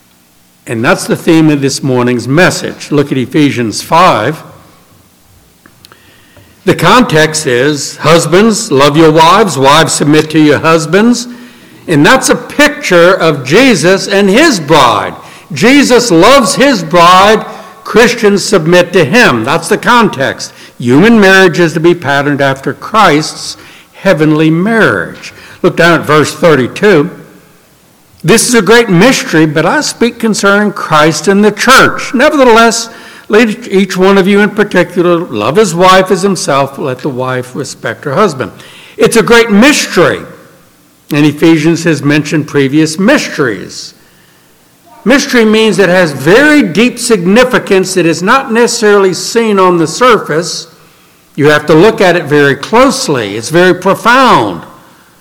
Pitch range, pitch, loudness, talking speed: 155-225 Hz, 185 Hz, -7 LUFS, 140 wpm